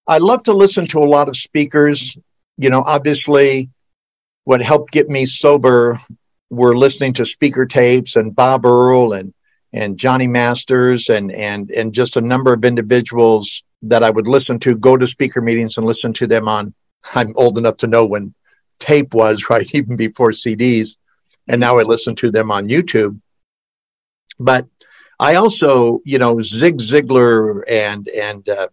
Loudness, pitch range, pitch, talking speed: -13 LUFS, 115-135 Hz, 125 Hz, 170 wpm